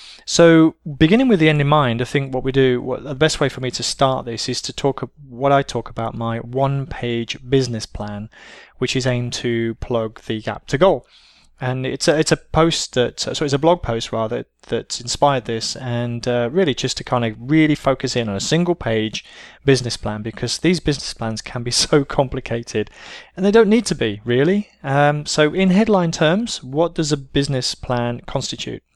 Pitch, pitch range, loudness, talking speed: 130 Hz, 120-150 Hz, -19 LUFS, 205 wpm